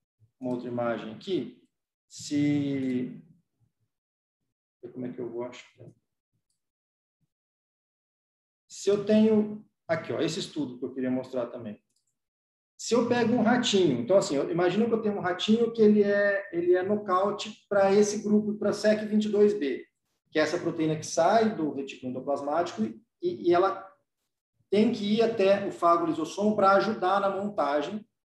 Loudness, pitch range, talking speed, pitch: -27 LUFS, 130-210 Hz, 155 wpm, 180 Hz